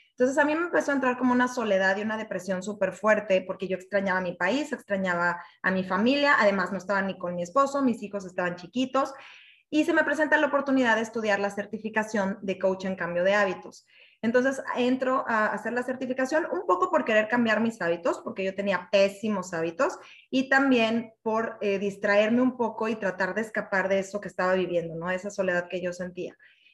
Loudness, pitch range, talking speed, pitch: -26 LUFS, 190-250 Hz, 205 wpm, 205 Hz